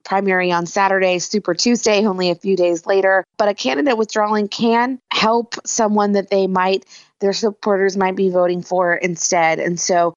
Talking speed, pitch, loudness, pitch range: 170 wpm, 195 Hz, -17 LUFS, 180-210 Hz